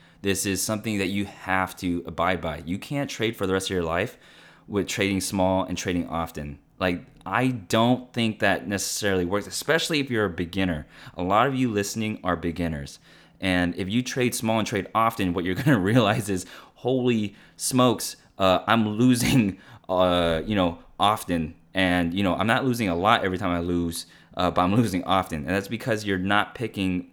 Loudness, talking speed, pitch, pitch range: -25 LUFS, 195 wpm, 95 Hz, 90-110 Hz